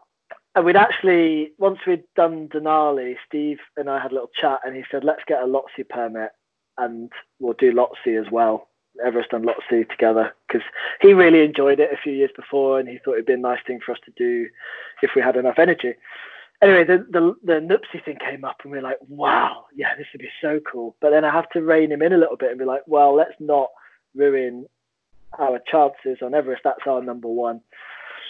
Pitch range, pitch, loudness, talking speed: 125-170 Hz, 145 Hz, -20 LUFS, 220 wpm